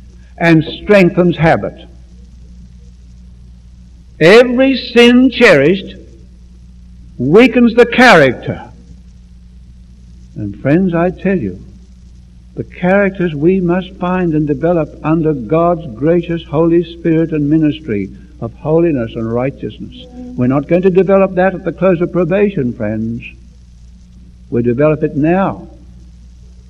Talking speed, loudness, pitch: 110 wpm, -12 LUFS, 145 Hz